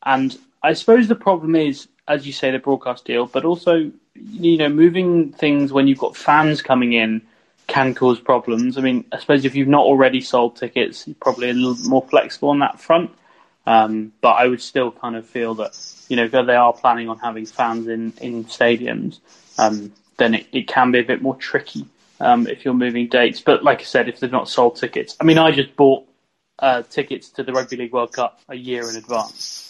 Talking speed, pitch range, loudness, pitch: 220 wpm, 120-145 Hz, -18 LUFS, 130 Hz